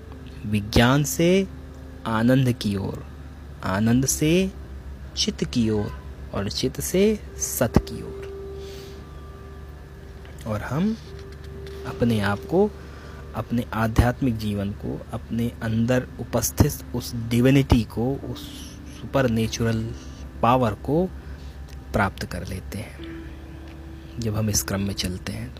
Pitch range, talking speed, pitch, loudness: 75-120 Hz, 115 wpm, 100 Hz, -24 LUFS